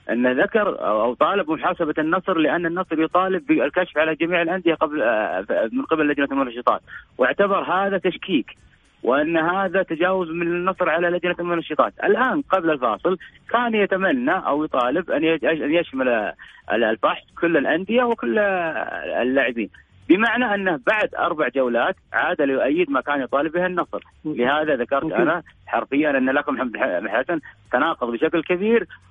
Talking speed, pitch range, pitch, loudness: 135 wpm, 160-190 Hz, 175 Hz, -21 LUFS